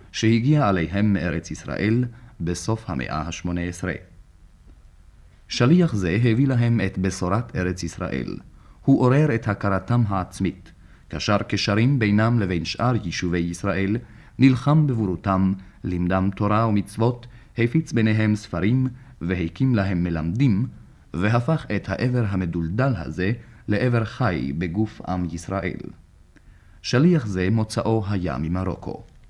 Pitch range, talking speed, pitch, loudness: 90-115 Hz, 110 wpm, 100 Hz, -23 LUFS